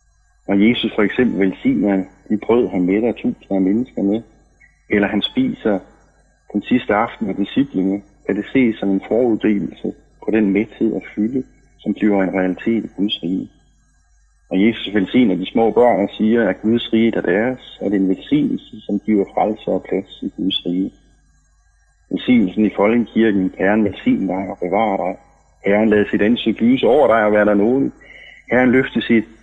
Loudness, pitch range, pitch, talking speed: -18 LUFS, 95-115 Hz, 105 Hz, 175 wpm